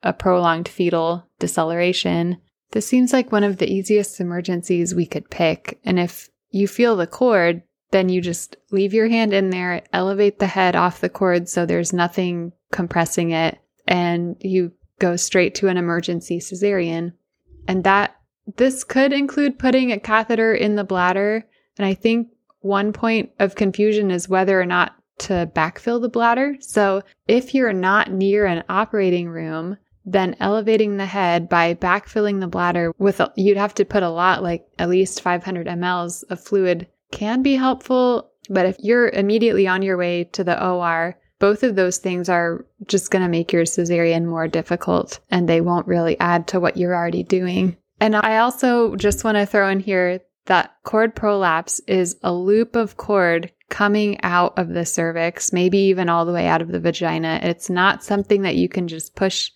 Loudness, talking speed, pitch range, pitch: -19 LUFS, 180 wpm, 175-210 Hz, 185 Hz